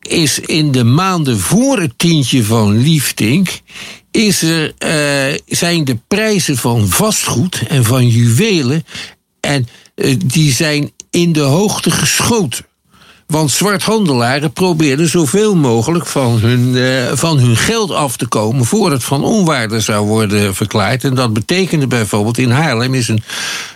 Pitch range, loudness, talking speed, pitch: 120-170 Hz, -12 LUFS, 140 wpm, 140 Hz